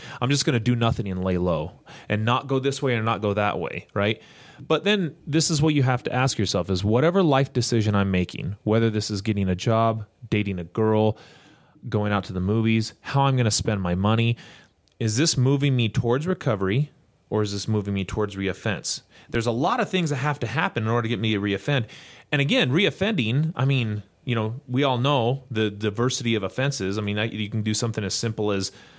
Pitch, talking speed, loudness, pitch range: 115 Hz, 225 wpm, -24 LUFS, 105-135 Hz